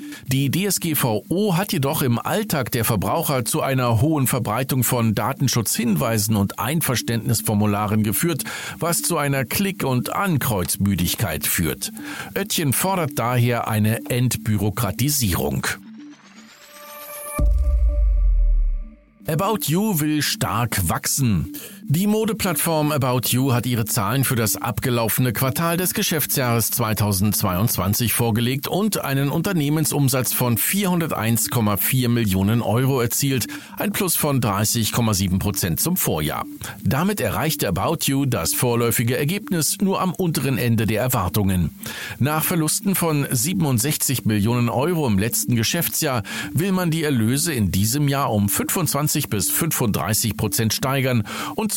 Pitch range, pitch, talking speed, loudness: 110-160 Hz, 130 Hz, 115 wpm, -20 LUFS